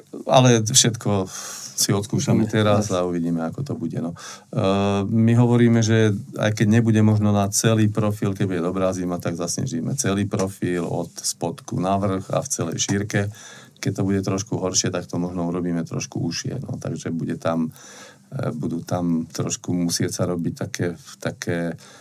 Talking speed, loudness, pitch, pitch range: 160 wpm, -22 LUFS, 100 Hz, 90-110 Hz